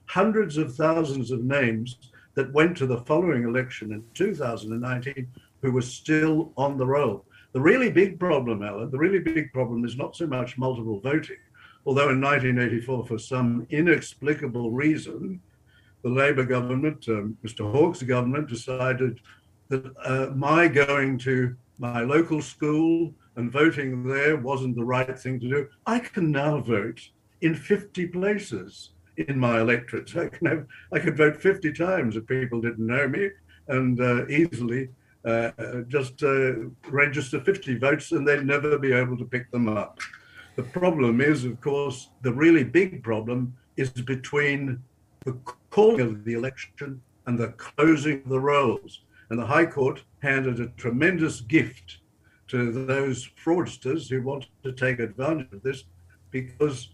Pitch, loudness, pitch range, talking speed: 130 Hz, -25 LUFS, 120-150 Hz, 155 wpm